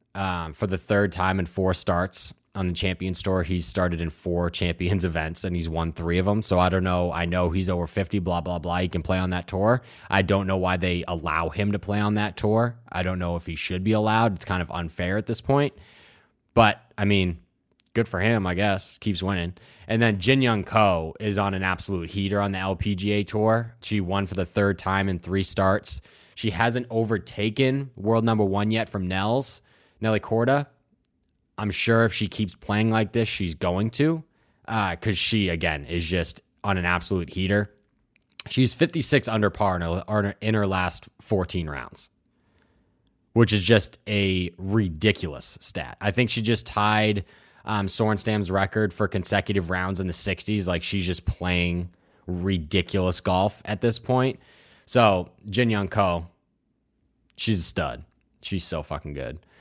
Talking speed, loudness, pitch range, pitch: 185 wpm, -25 LUFS, 90-110 Hz, 100 Hz